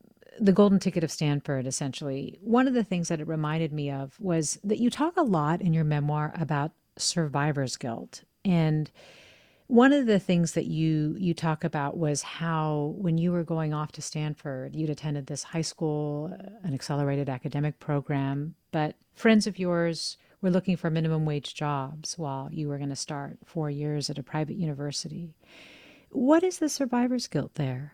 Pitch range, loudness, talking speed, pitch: 145-180 Hz, -28 LUFS, 175 wpm, 155 Hz